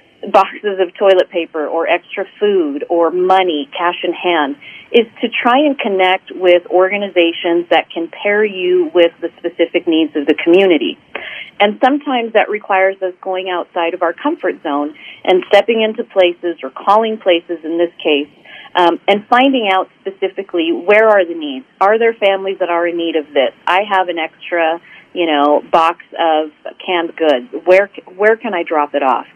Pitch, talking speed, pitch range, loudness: 185 Hz, 175 wpm, 170-210 Hz, -14 LUFS